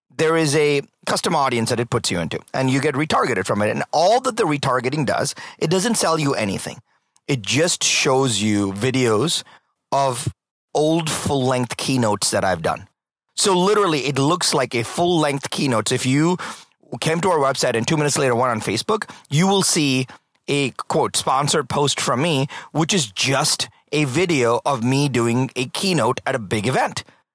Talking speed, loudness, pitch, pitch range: 185 wpm, -19 LUFS, 140 Hz, 125-160 Hz